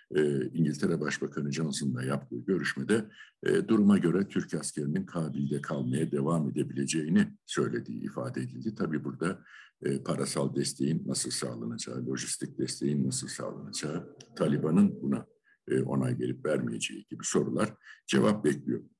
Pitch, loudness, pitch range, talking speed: 70 Hz, -31 LUFS, 65-80 Hz, 125 wpm